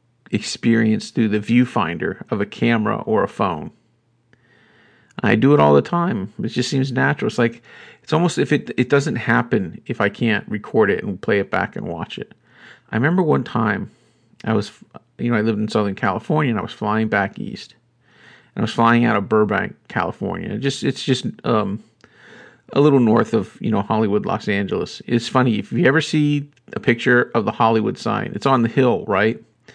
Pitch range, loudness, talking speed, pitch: 110-130 Hz, -19 LUFS, 200 wpm, 120 Hz